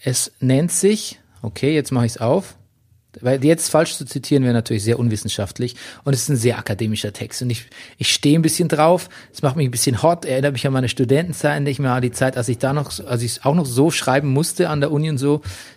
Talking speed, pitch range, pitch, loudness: 245 wpm, 120-150 Hz, 135 Hz, -19 LUFS